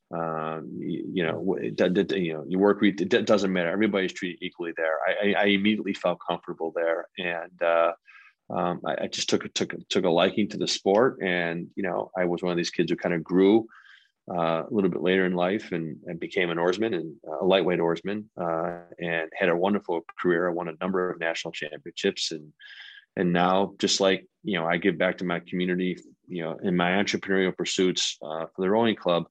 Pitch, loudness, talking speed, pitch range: 90 Hz, -26 LUFS, 210 wpm, 85-95 Hz